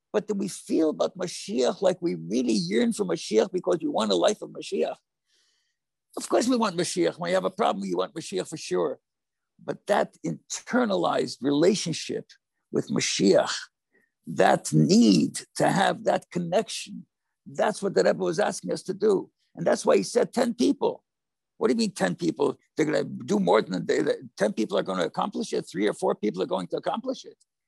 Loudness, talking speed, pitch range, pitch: -26 LUFS, 195 wpm, 175-285 Hz, 205 Hz